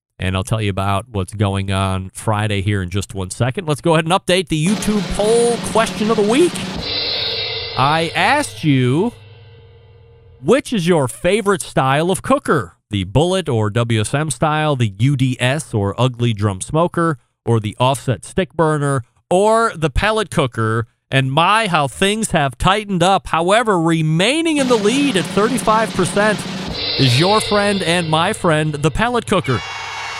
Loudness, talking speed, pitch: -17 LUFS, 155 wpm, 160 Hz